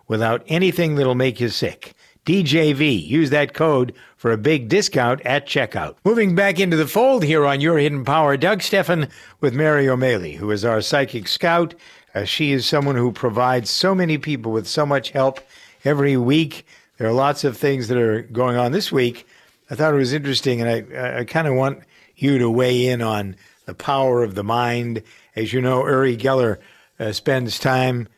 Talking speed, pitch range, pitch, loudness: 195 wpm, 120-155 Hz, 135 Hz, -19 LUFS